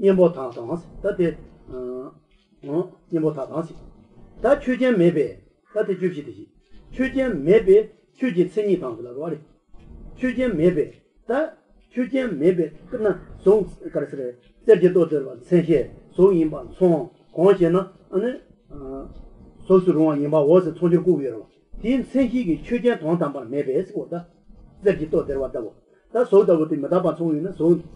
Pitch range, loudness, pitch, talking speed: 160-215 Hz, -21 LUFS, 180 Hz, 105 wpm